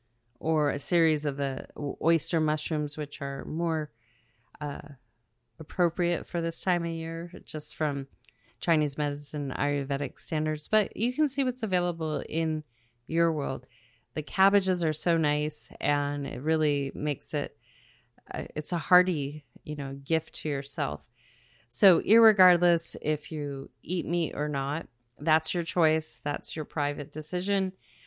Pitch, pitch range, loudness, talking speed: 155 Hz, 140-170 Hz, -28 LUFS, 140 wpm